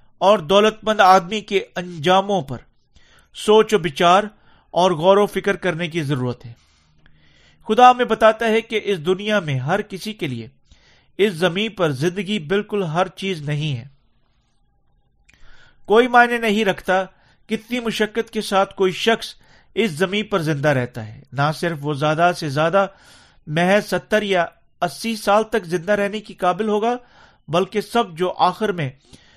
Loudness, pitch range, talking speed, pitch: -19 LUFS, 160-215 Hz, 155 wpm, 190 Hz